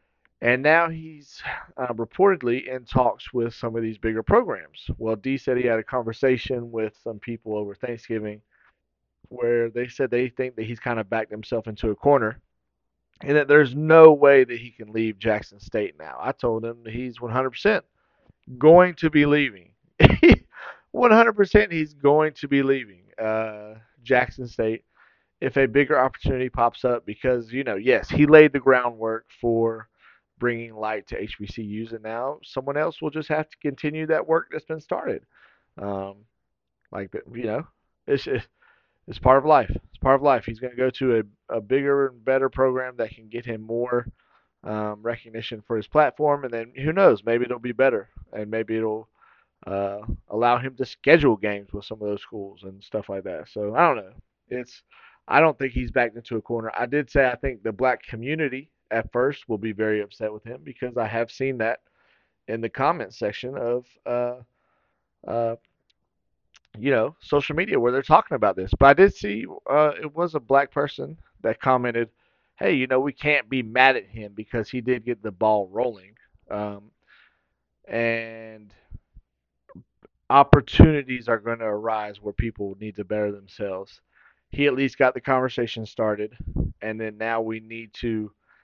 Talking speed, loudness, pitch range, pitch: 185 wpm, -22 LUFS, 110-135 Hz, 120 Hz